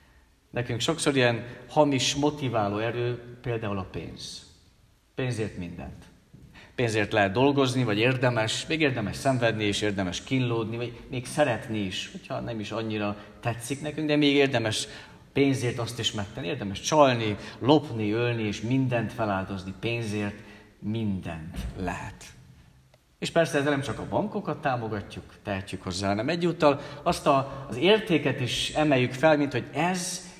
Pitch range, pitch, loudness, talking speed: 105-140 Hz, 120 Hz, -27 LUFS, 140 wpm